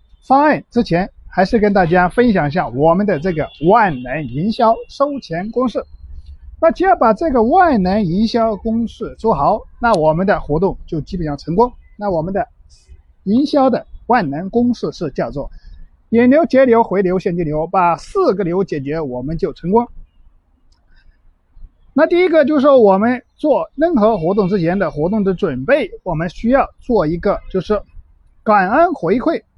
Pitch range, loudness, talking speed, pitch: 180-245 Hz, -15 LUFS, 245 characters per minute, 210 Hz